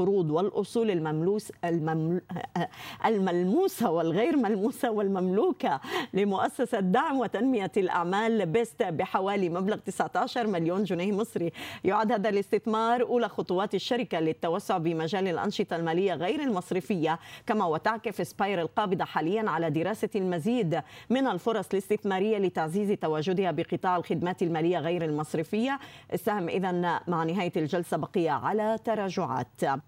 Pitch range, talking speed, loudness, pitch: 170-220 Hz, 115 wpm, -28 LUFS, 195 Hz